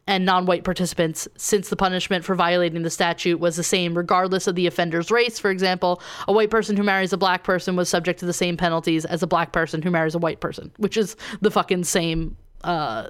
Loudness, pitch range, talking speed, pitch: -22 LUFS, 175-195 Hz, 225 wpm, 180 Hz